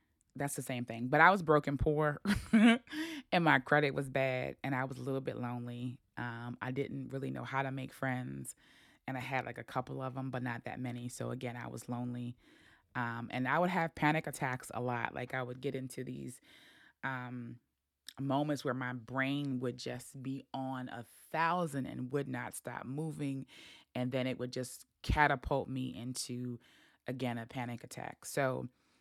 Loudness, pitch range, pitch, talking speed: -36 LUFS, 125-140 Hz, 130 Hz, 190 wpm